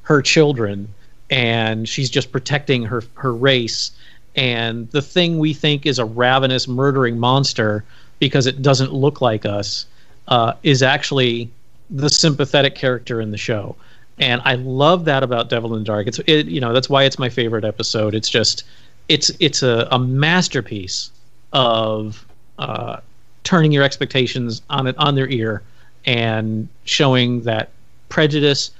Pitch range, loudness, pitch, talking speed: 115-140 Hz, -17 LUFS, 125 Hz, 155 wpm